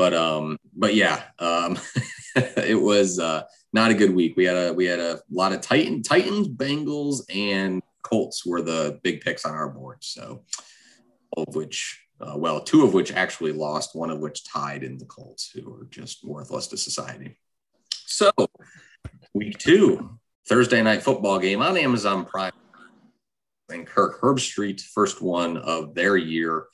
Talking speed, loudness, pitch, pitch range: 170 wpm, -23 LUFS, 90 Hz, 80-110 Hz